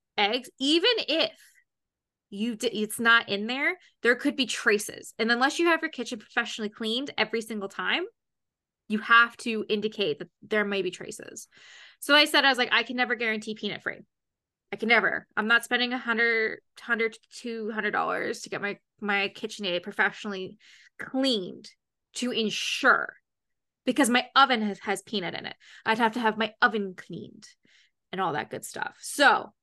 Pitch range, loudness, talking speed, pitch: 210-245 Hz, -26 LUFS, 180 wpm, 225 Hz